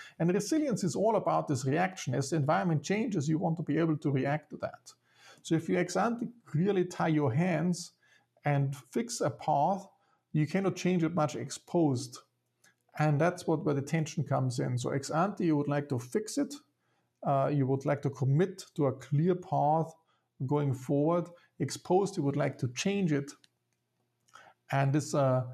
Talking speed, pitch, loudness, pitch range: 185 wpm, 155 Hz, -31 LUFS, 140-180 Hz